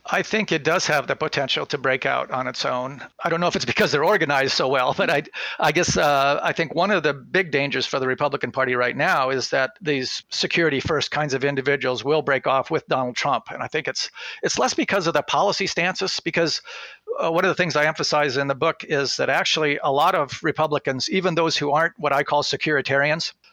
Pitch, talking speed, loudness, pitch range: 150 Hz, 235 wpm, -21 LUFS, 140-170 Hz